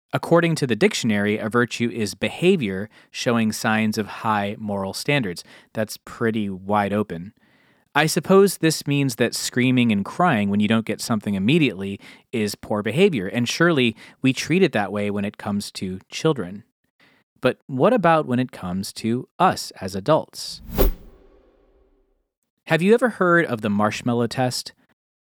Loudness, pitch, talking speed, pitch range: -21 LUFS, 120 Hz, 155 wpm, 105-160 Hz